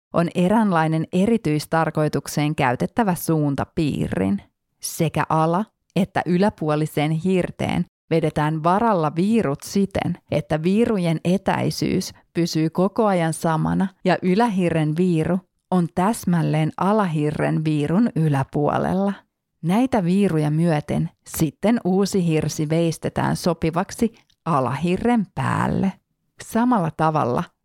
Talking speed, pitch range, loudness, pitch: 90 wpm, 155-190 Hz, -21 LUFS, 170 Hz